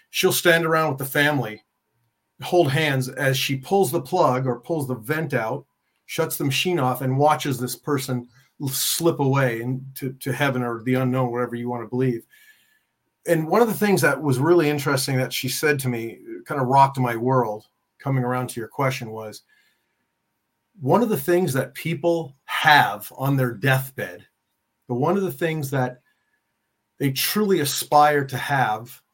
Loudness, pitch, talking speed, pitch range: -22 LUFS, 135 Hz, 175 wpm, 125-160 Hz